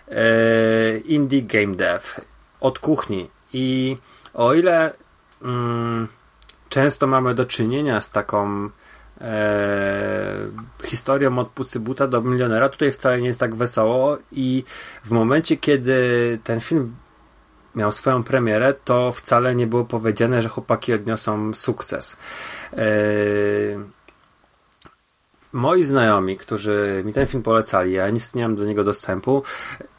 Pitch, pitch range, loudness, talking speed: 115 Hz, 105-130 Hz, -20 LUFS, 120 wpm